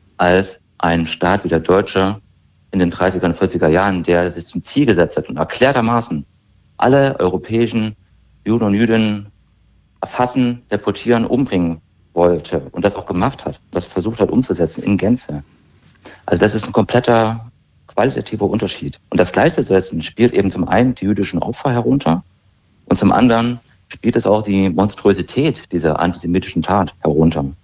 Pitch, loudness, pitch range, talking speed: 95 Hz, -16 LUFS, 85-110 Hz, 150 wpm